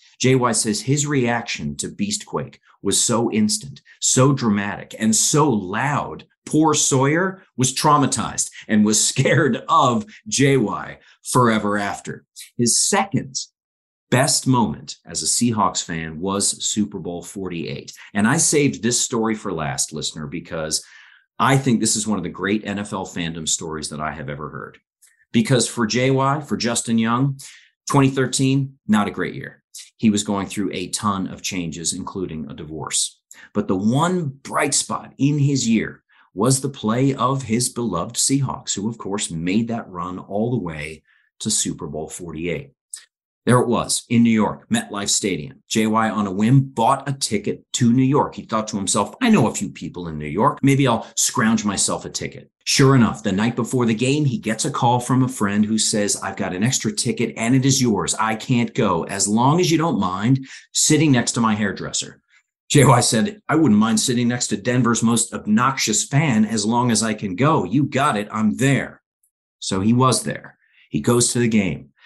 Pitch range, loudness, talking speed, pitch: 105-135 Hz, -19 LUFS, 180 wpm, 115 Hz